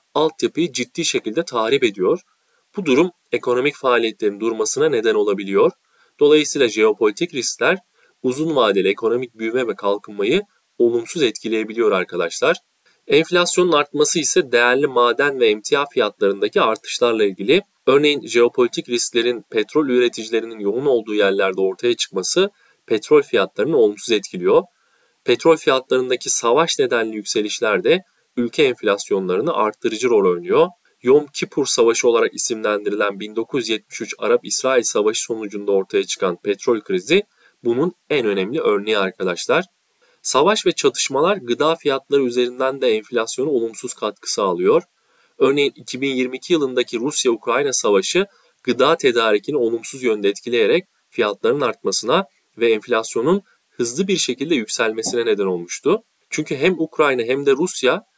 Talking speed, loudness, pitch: 120 wpm, -18 LUFS, 175 Hz